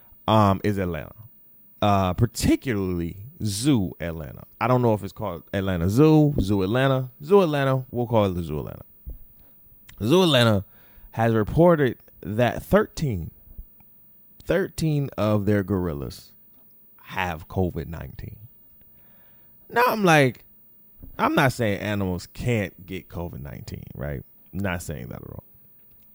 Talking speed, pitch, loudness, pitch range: 125 wpm, 105 Hz, -23 LUFS, 95-125 Hz